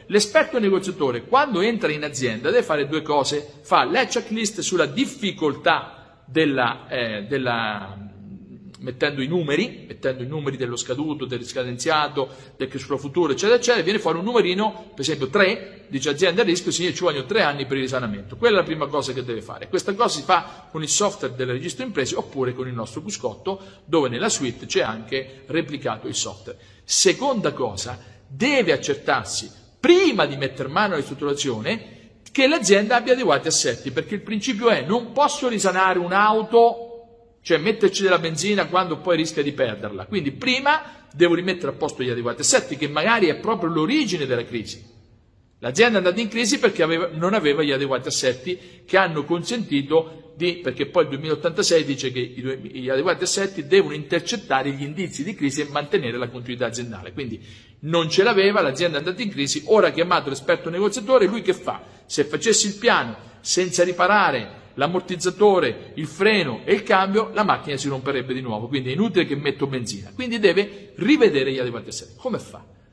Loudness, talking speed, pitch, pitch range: -21 LUFS, 180 wpm, 160 Hz, 130-200 Hz